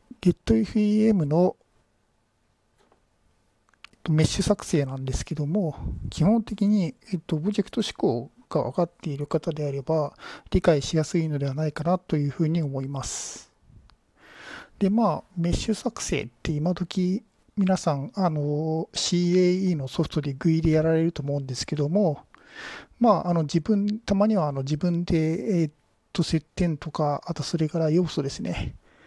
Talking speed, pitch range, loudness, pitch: 275 characters per minute, 150-190 Hz, -25 LUFS, 165 Hz